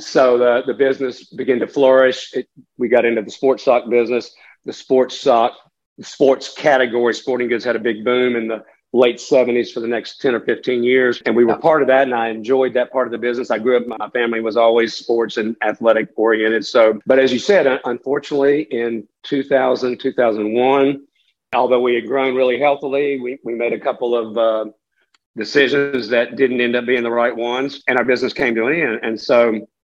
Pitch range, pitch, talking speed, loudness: 115-130 Hz, 120 Hz, 205 wpm, -17 LUFS